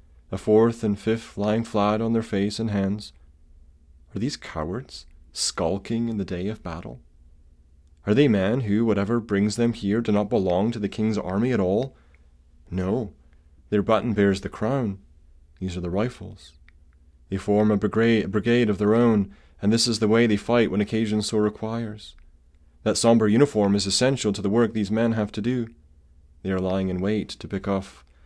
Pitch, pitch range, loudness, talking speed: 100 Hz, 75-110 Hz, -24 LUFS, 185 wpm